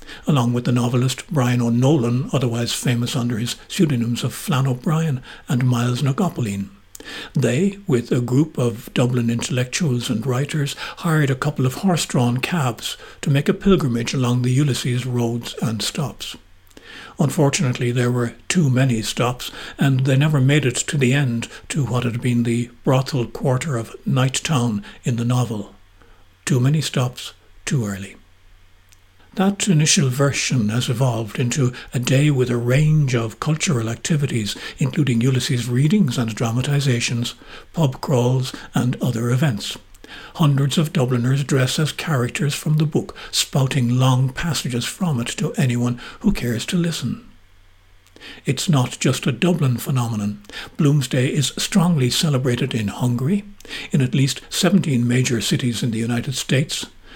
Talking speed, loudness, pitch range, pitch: 145 wpm, -20 LUFS, 120-145 Hz, 130 Hz